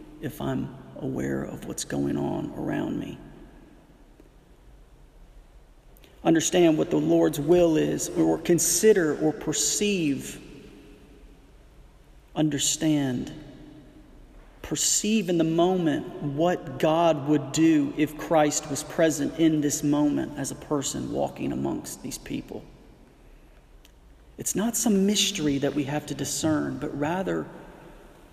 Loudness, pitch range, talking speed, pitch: -25 LUFS, 145-170 Hz, 110 wpm, 155 Hz